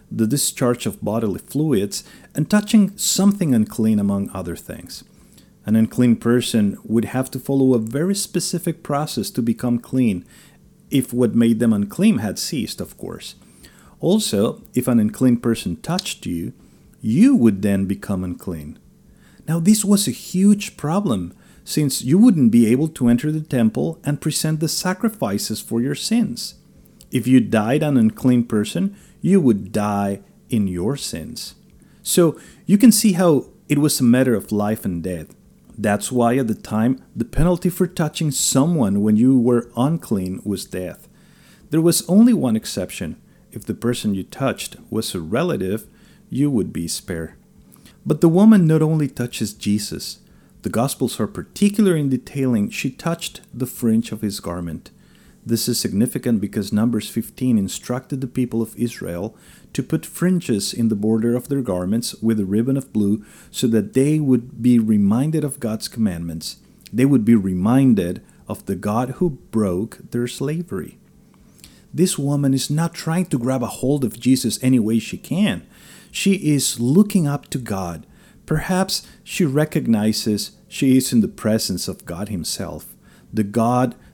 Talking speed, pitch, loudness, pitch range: 160 wpm, 125 Hz, -19 LUFS, 110-165 Hz